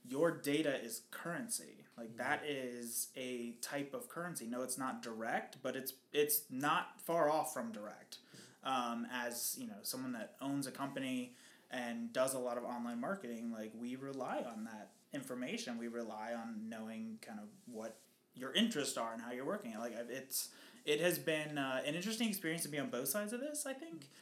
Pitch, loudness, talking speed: 135 Hz, -41 LUFS, 190 wpm